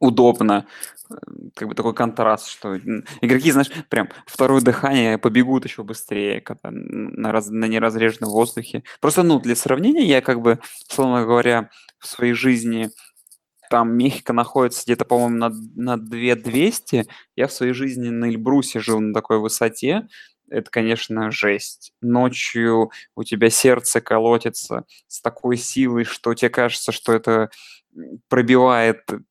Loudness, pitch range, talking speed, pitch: -19 LUFS, 115-125 Hz, 135 wpm, 120 Hz